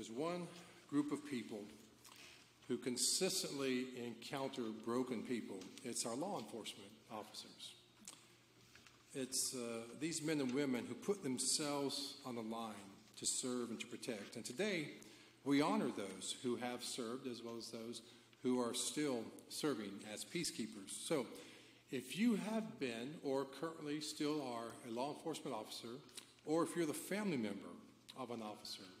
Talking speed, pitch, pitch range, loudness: 150 wpm, 125 Hz, 115-145 Hz, -43 LUFS